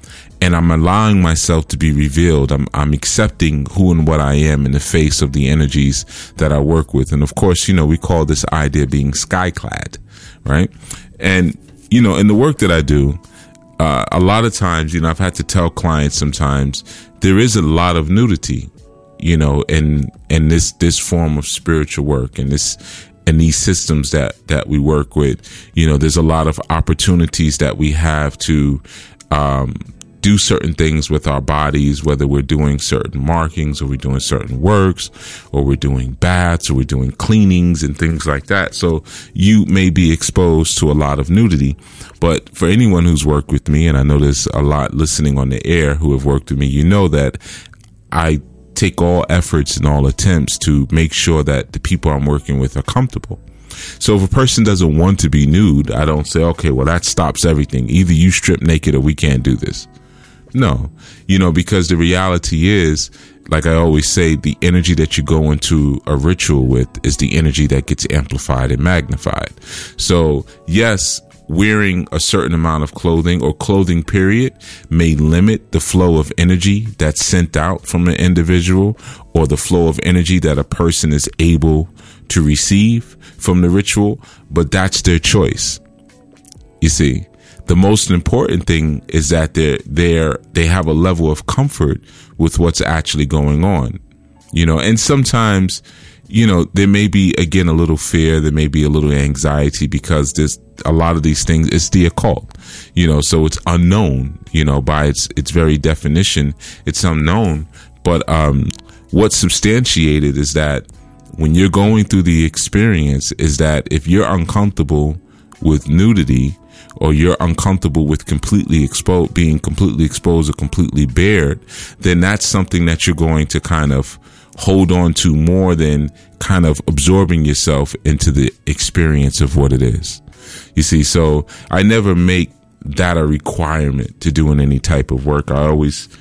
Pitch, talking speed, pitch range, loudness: 80 Hz, 180 wpm, 75-90 Hz, -14 LUFS